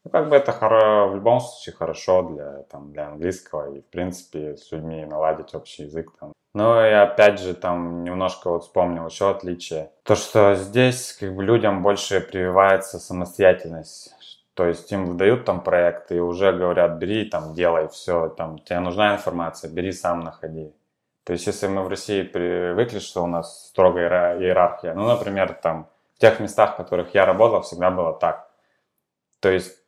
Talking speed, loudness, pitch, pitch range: 170 wpm, -21 LUFS, 90 Hz, 85-100 Hz